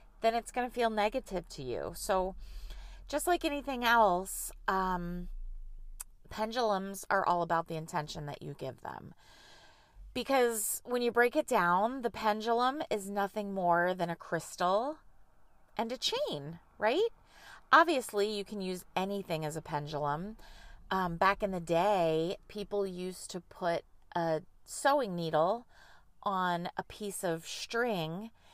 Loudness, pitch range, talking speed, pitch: -33 LUFS, 175-230 Hz, 140 wpm, 195 Hz